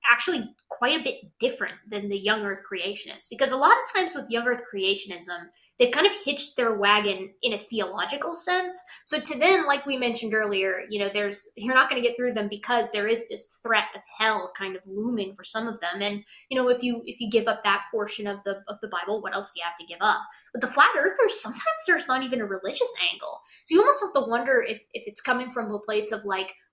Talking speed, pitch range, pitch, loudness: 245 wpm, 200-270 Hz, 225 Hz, -25 LUFS